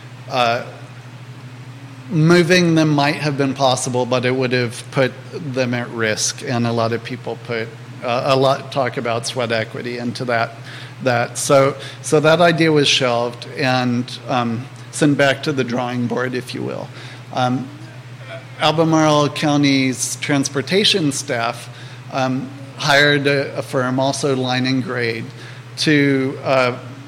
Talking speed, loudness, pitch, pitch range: 140 wpm, -18 LUFS, 130 Hz, 125-140 Hz